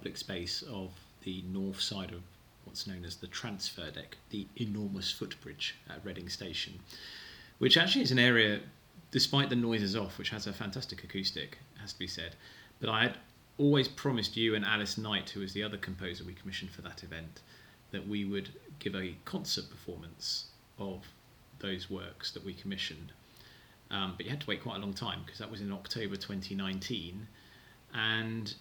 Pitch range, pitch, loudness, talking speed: 95-115 Hz, 100 Hz, -34 LUFS, 180 wpm